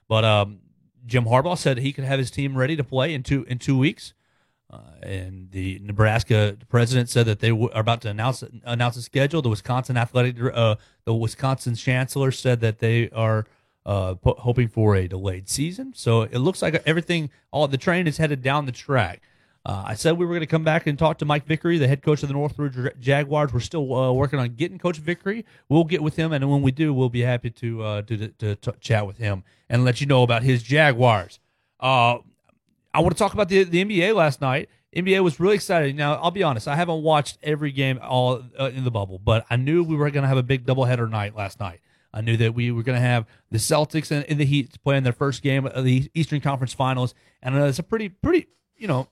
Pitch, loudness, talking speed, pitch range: 130 Hz, -22 LUFS, 240 wpm, 115-150 Hz